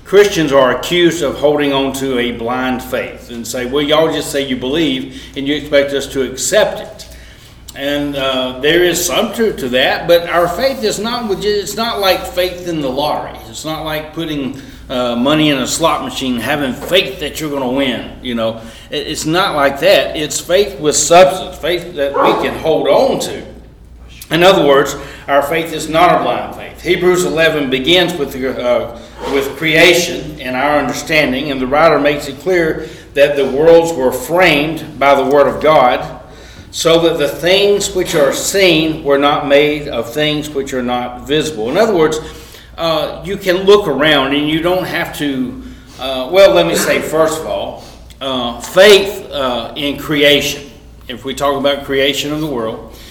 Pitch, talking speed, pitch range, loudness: 150 Hz, 190 wpm, 135-170 Hz, -13 LUFS